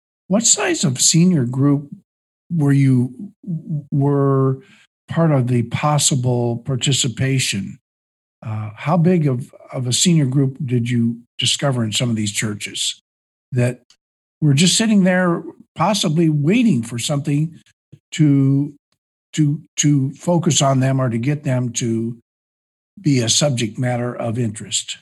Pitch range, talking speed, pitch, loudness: 120-160 Hz, 130 wpm, 140 Hz, -18 LUFS